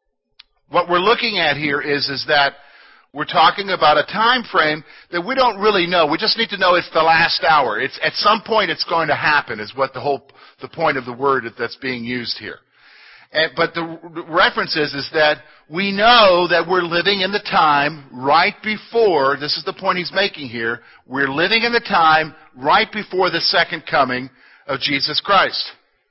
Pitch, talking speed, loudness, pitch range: 165 Hz, 200 wpm, -17 LUFS, 140-195 Hz